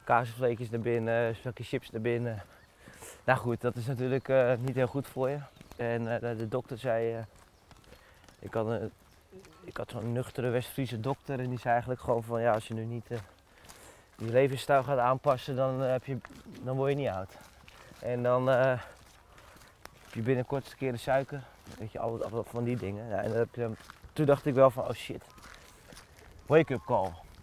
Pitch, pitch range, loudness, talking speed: 120 Hz, 115-130 Hz, -31 LUFS, 195 wpm